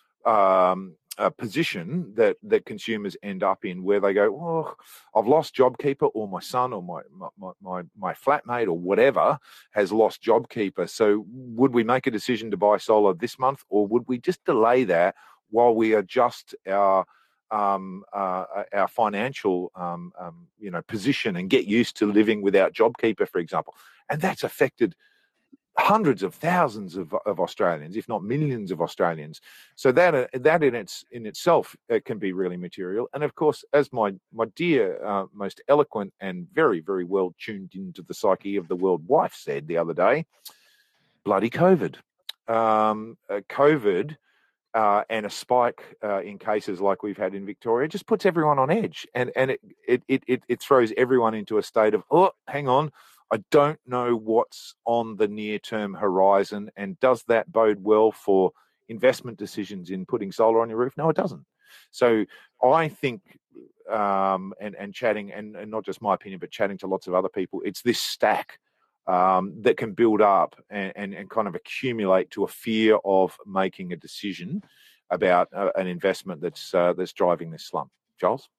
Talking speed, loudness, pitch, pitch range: 180 wpm, -24 LUFS, 110 Hz, 95-130 Hz